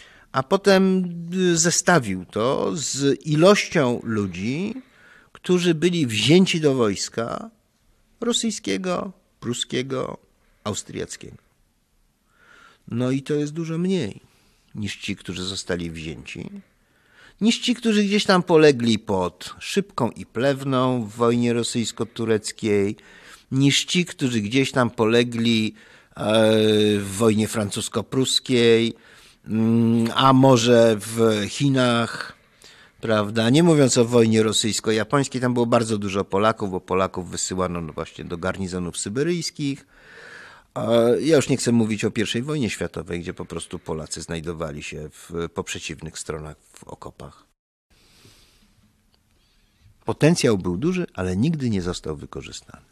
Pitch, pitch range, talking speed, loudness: 115 Hz, 95-140 Hz, 115 wpm, -21 LUFS